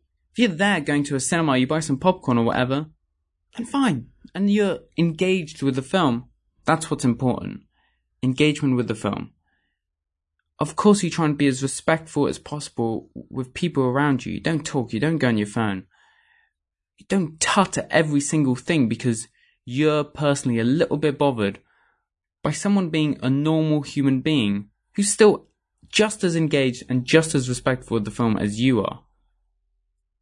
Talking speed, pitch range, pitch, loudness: 175 wpm, 120-160 Hz, 140 Hz, -22 LUFS